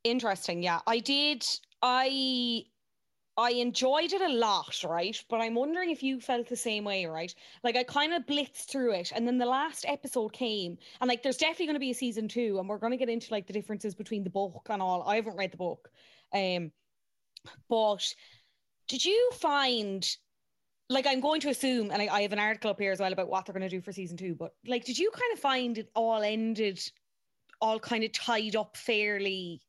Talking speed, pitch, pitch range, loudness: 220 wpm, 230 Hz, 200-260 Hz, -31 LUFS